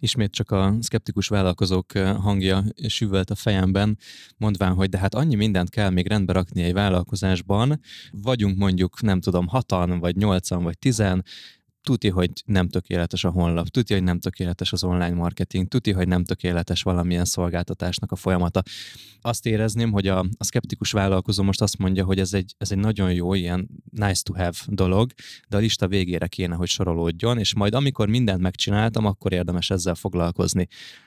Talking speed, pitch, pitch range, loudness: 170 wpm, 95 Hz, 90-105 Hz, -23 LUFS